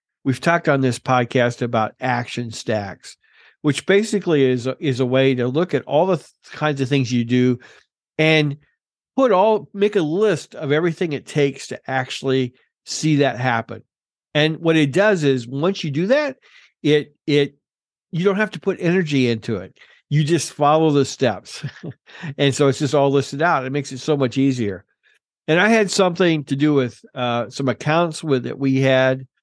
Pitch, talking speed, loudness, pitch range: 140 Hz, 190 wpm, -19 LUFS, 130-160 Hz